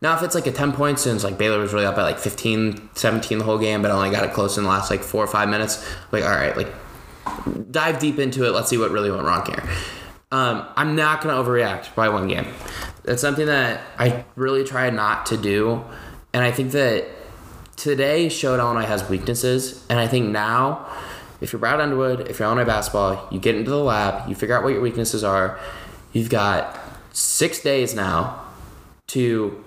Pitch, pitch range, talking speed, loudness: 115 Hz, 105-135 Hz, 210 wpm, -21 LUFS